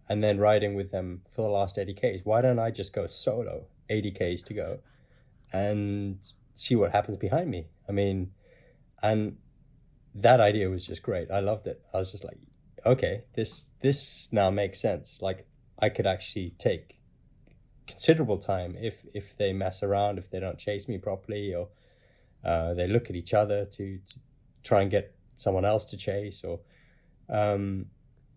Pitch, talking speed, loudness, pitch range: 105 Hz, 175 wpm, -29 LUFS, 95-120 Hz